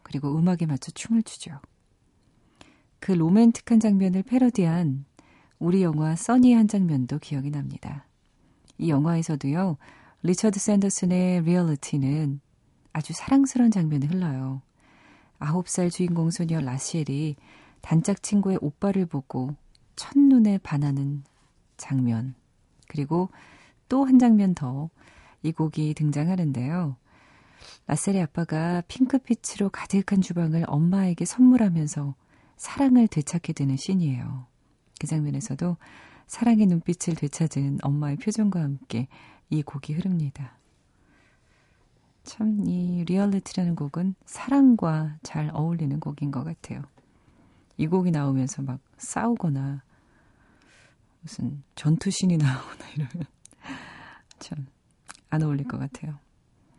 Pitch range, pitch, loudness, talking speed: 140-190 Hz, 160 Hz, -25 LUFS, 260 characters per minute